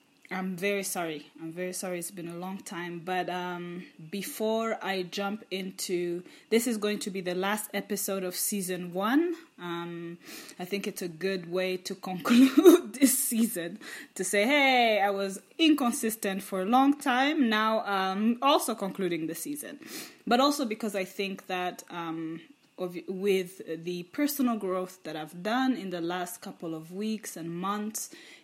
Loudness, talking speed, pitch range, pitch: -29 LUFS, 165 wpm, 180-235 Hz, 195 Hz